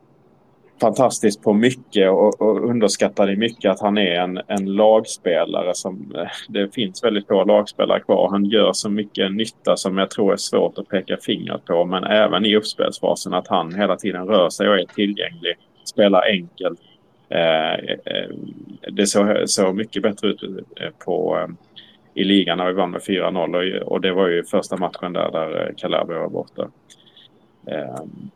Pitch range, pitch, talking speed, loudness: 90-105 Hz, 100 Hz, 160 wpm, -19 LUFS